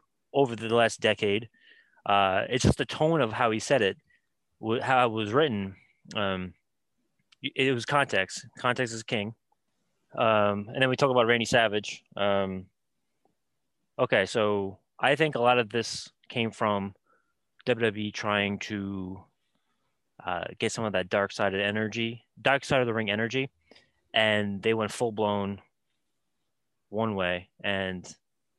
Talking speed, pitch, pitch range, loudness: 145 wpm, 110 Hz, 100-120 Hz, -27 LUFS